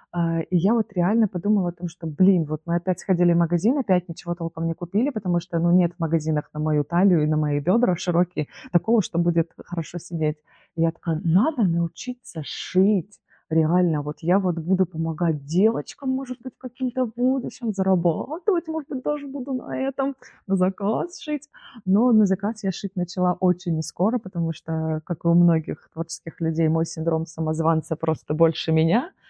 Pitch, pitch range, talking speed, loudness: 175 Hz, 165-215 Hz, 180 wpm, -23 LUFS